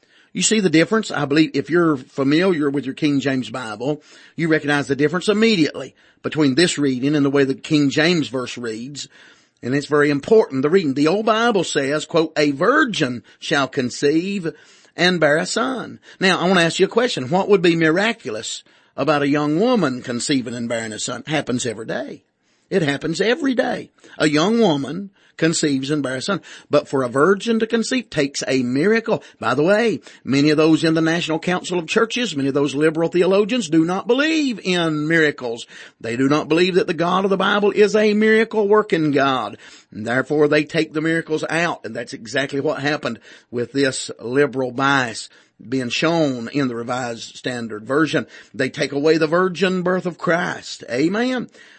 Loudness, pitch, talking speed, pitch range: -19 LUFS, 155 Hz, 190 wpm, 140-190 Hz